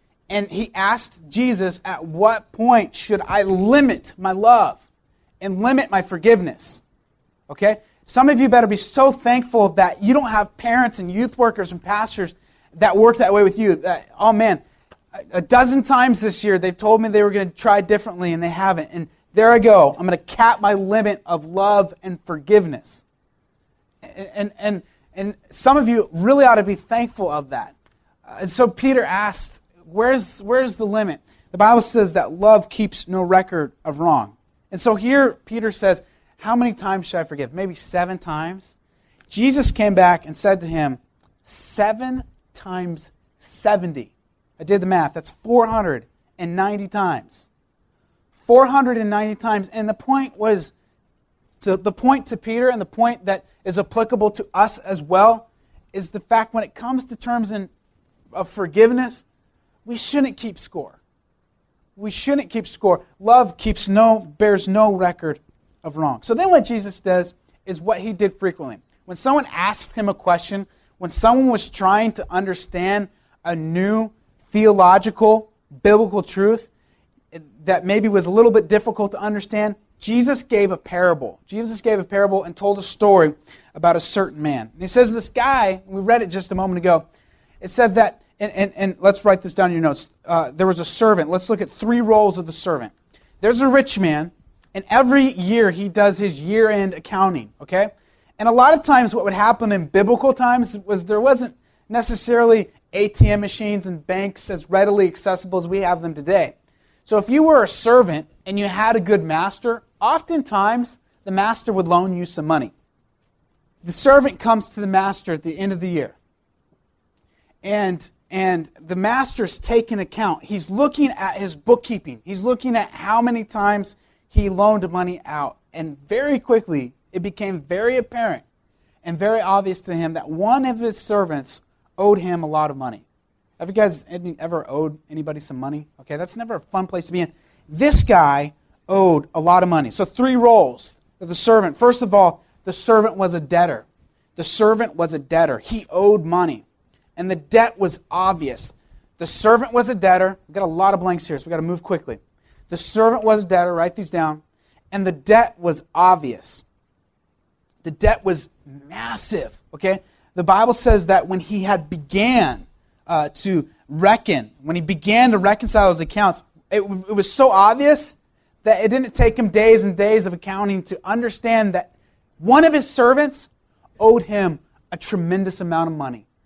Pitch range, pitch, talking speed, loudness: 180-225 Hz, 200 Hz, 175 wpm, -18 LUFS